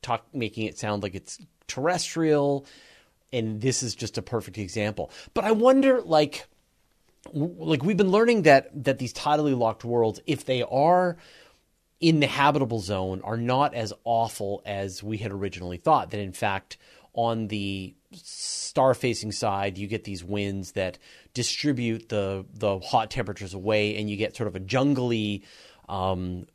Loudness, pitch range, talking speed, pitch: -26 LUFS, 100-140 Hz, 165 wpm, 115 Hz